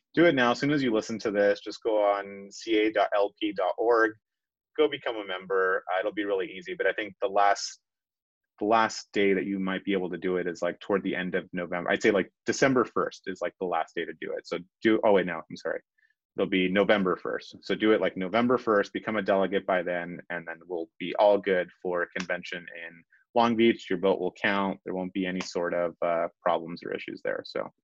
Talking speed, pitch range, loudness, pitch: 235 wpm, 90-115 Hz, -28 LUFS, 100 Hz